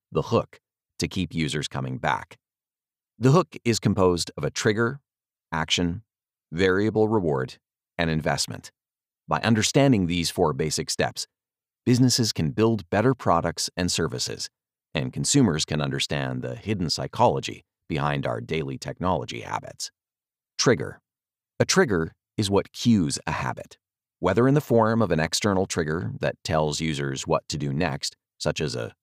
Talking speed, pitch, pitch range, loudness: 145 wpm, 90 Hz, 80-110 Hz, -24 LUFS